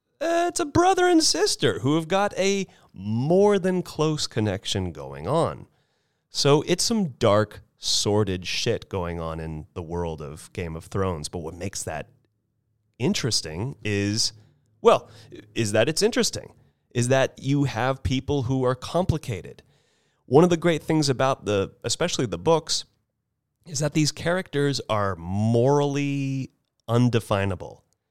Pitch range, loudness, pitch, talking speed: 105-155 Hz, -24 LUFS, 125 Hz, 145 wpm